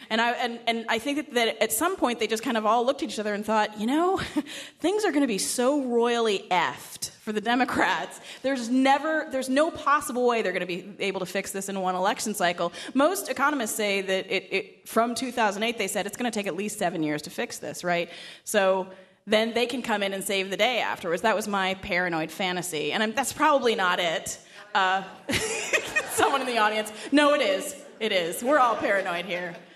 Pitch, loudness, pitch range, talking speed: 220 Hz, -26 LUFS, 190-260 Hz, 220 wpm